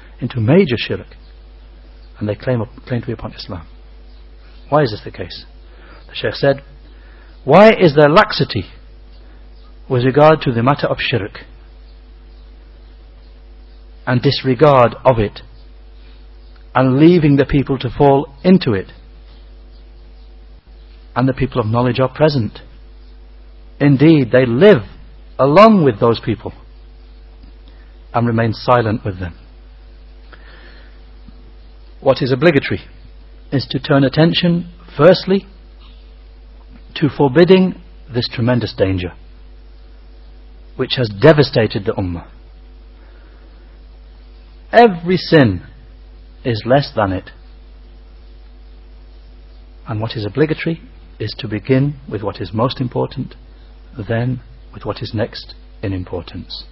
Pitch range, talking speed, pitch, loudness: 85-135 Hz, 110 wpm, 110 Hz, -14 LUFS